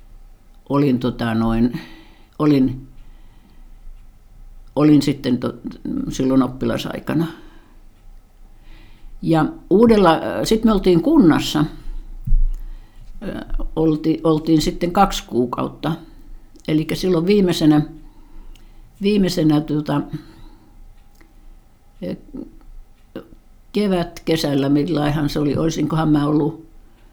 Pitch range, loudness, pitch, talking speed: 115-165 Hz, -18 LUFS, 150 Hz, 75 wpm